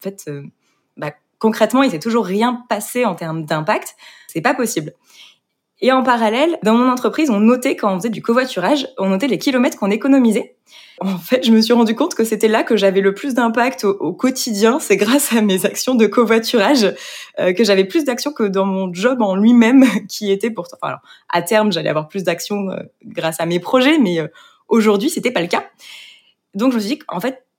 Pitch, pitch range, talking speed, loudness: 225 Hz, 195-250 Hz, 215 wpm, -16 LUFS